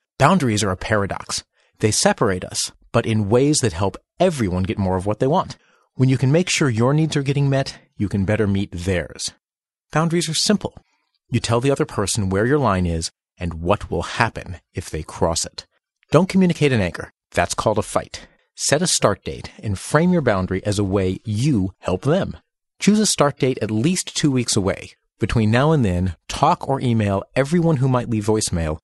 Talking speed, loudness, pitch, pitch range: 200 wpm, -20 LUFS, 115 Hz, 100-145 Hz